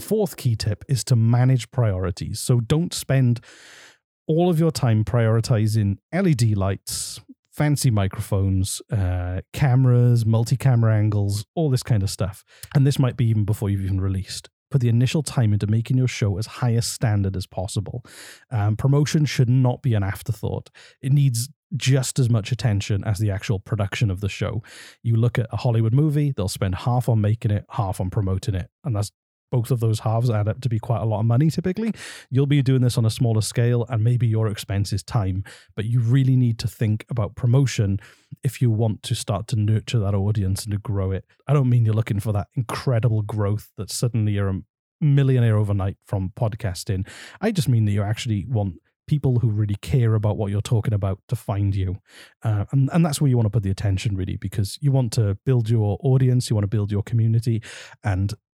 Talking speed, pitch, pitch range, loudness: 205 wpm, 115 Hz, 105-130 Hz, -22 LUFS